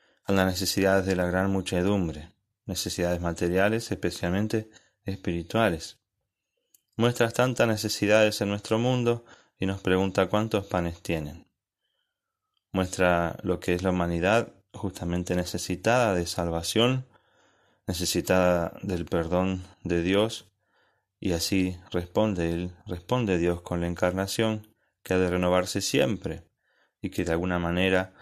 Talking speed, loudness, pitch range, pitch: 120 wpm, -27 LUFS, 90-105 Hz, 95 Hz